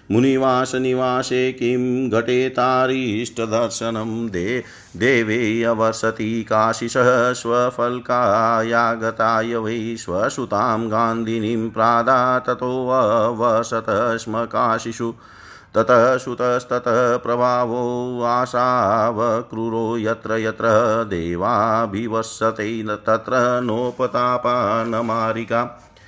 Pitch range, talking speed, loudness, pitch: 115-125 Hz, 55 wpm, -19 LUFS, 115 Hz